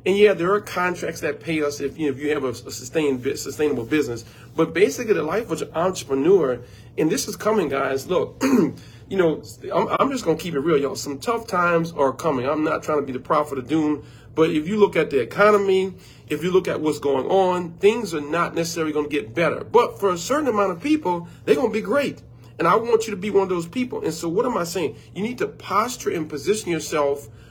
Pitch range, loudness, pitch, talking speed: 145-195 Hz, -22 LUFS, 160 Hz, 245 wpm